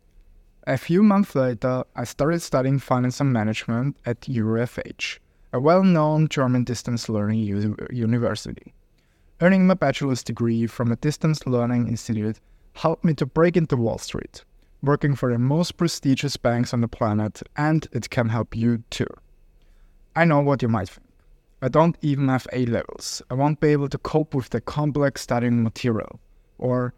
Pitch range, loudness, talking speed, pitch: 115-145 Hz, -23 LUFS, 165 wpm, 125 Hz